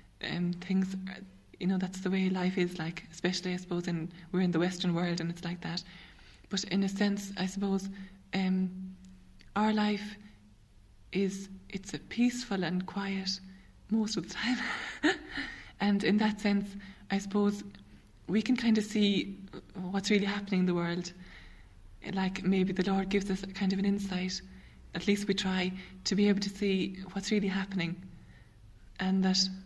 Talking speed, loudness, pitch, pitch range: 170 wpm, -32 LUFS, 190 Hz, 180-200 Hz